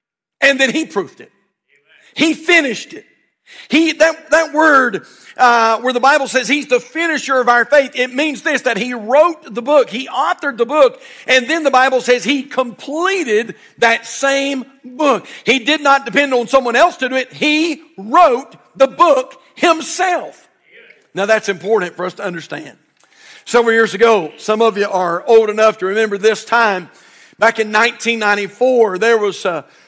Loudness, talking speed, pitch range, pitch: -14 LUFS, 175 wpm, 225-300 Hz, 255 Hz